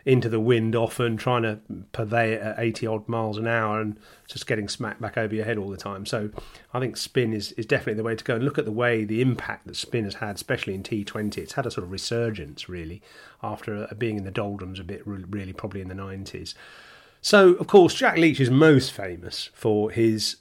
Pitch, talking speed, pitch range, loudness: 110 Hz, 230 wpm, 105-120 Hz, -24 LUFS